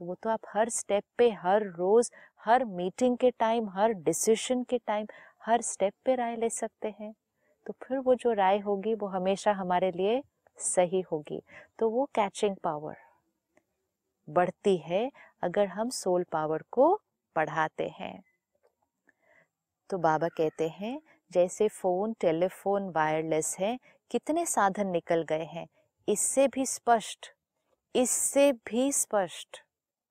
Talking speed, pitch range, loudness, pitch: 135 wpm, 180-235 Hz, -29 LUFS, 210 Hz